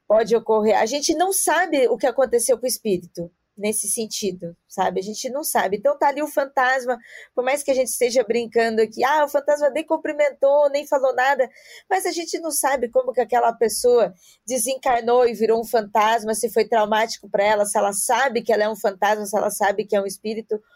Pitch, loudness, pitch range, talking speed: 240 Hz, -21 LUFS, 215-285 Hz, 215 wpm